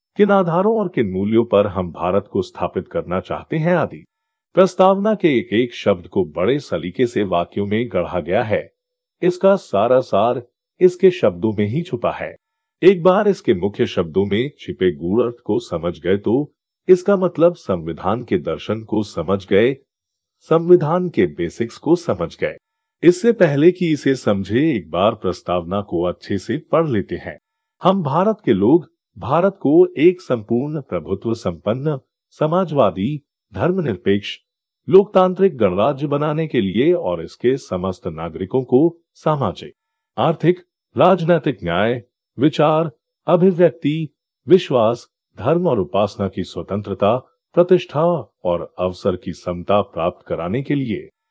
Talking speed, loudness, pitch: 140 wpm, -18 LUFS, 155 Hz